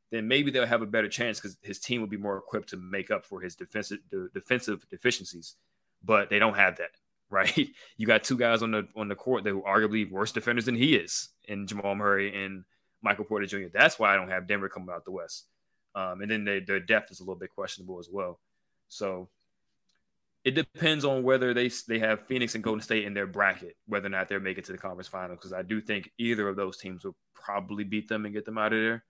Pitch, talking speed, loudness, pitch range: 105 Hz, 245 wpm, -29 LUFS, 100-115 Hz